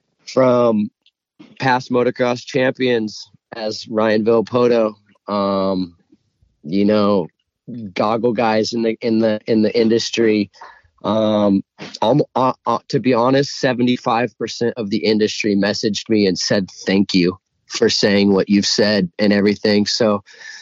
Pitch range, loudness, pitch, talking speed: 100-120 Hz, -17 LUFS, 110 Hz, 130 wpm